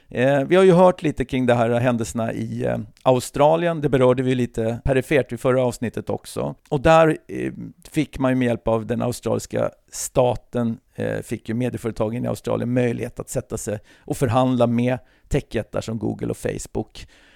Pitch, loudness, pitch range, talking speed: 125 Hz, -21 LUFS, 115-130 Hz, 180 wpm